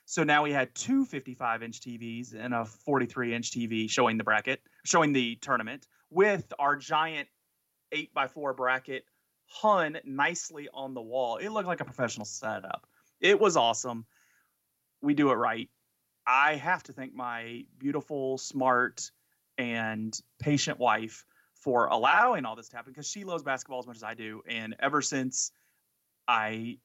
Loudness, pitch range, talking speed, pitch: -29 LUFS, 115-145 Hz, 165 wpm, 130 Hz